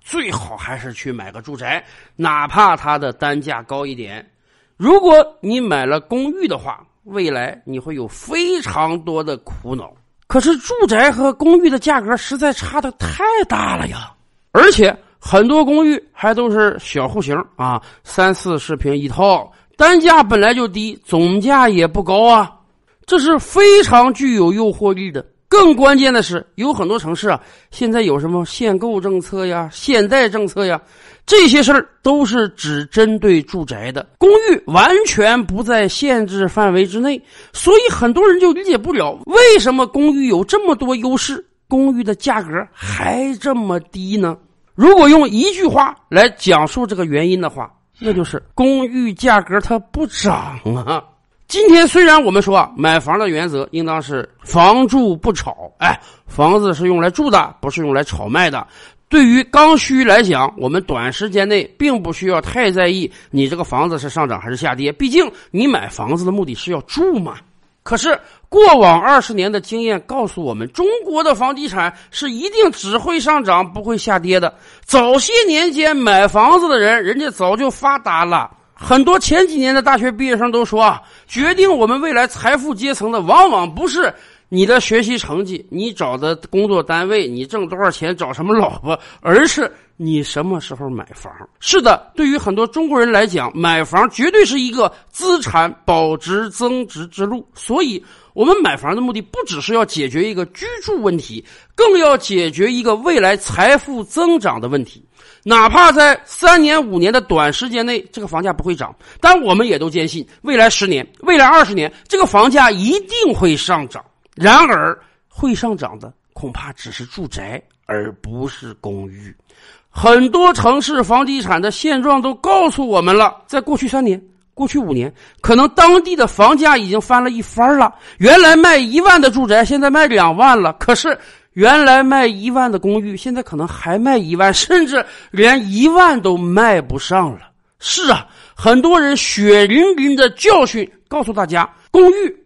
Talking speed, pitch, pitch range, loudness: 260 characters per minute, 230 Hz, 175-290 Hz, -13 LUFS